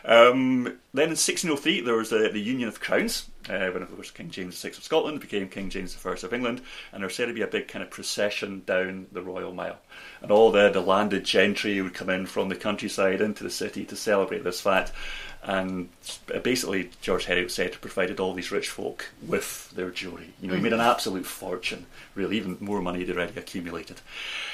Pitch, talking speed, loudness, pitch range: 95 Hz, 215 wpm, -27 LUFS, 90-115 Hz